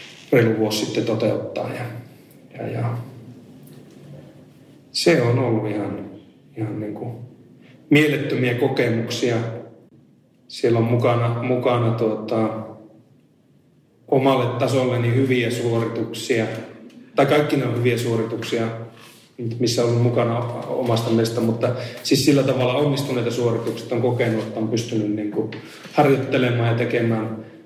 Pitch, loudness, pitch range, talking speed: 120 Hz, -21 LUFS, 115-125 Hz, 115 wpm